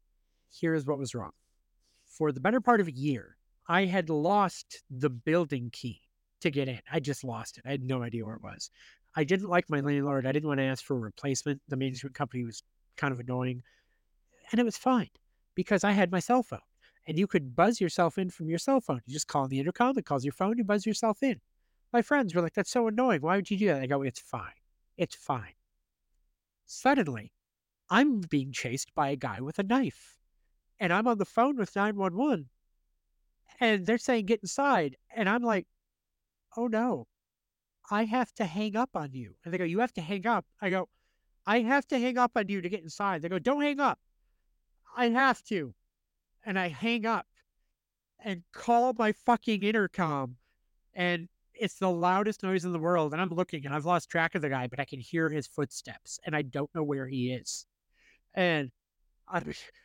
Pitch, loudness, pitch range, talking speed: 175 Hz, -30 LUFS, 135-220 Hz, 210 wpm